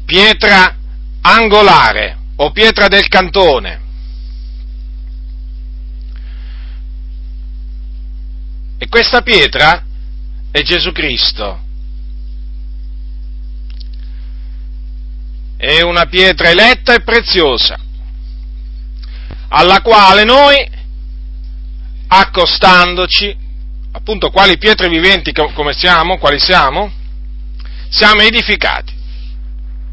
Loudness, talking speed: -8 LUFS, 65 wpm